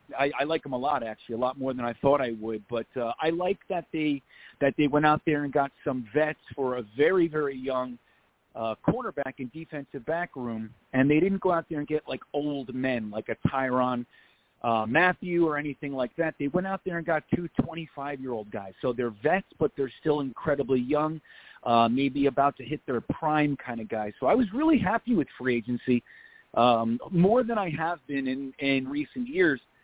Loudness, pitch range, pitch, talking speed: -28 LUFS, 125-160 Hz, 140 Hz, 215 wpm